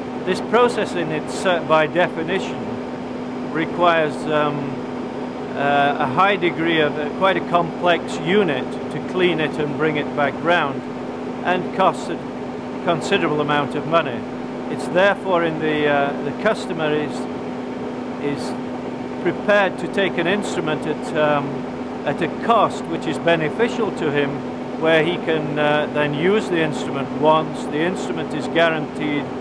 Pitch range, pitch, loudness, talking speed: 140-165 Hz, 150 Hz, -20 LUFS, 145 wpm